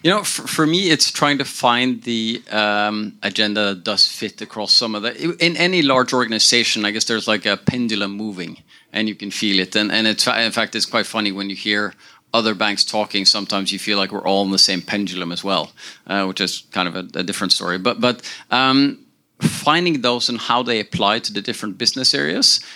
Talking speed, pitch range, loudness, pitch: 220 wpm, 100-120 Hz, -18 LUFS, 110 Hz